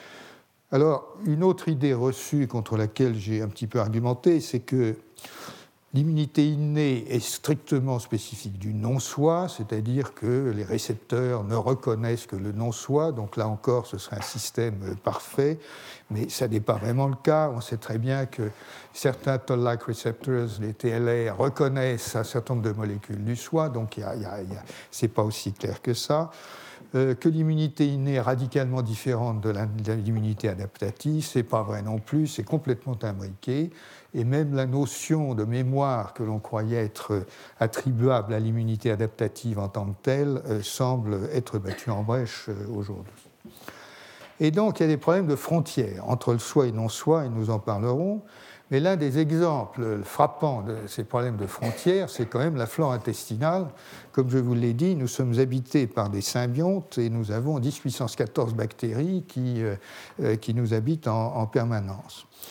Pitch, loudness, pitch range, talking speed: 120 Hz, -27 LUFS, 110-140 Hz, 170 wpm